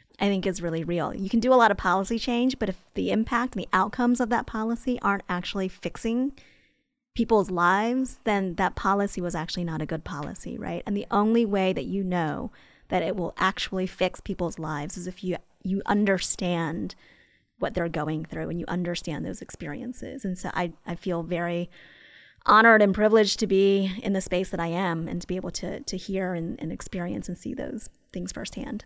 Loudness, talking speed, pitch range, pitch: -26 LUFS, 205 wpm, 175-225 Hz, 190 Hz